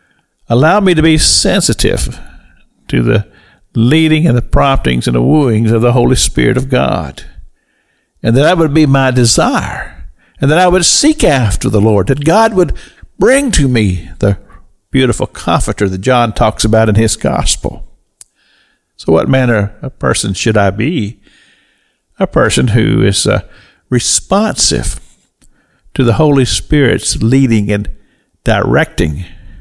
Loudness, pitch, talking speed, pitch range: -11 LUFS, 115 Hz, 145 wpm, 100-135 Hz